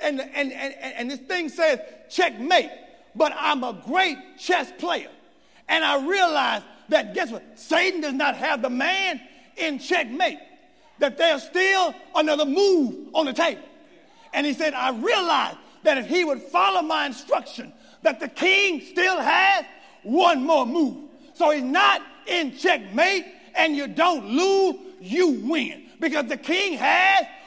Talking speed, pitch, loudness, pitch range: 155 wpm, 320 Hz, -22 LUFS, 285-355 Hz